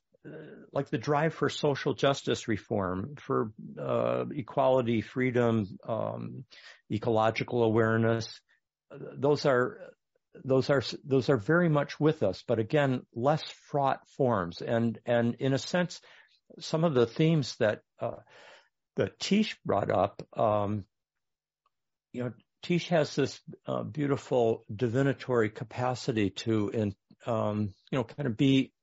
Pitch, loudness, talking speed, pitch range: 125 Hz, -29 LUFS, 130 wpm, 110-145 Hz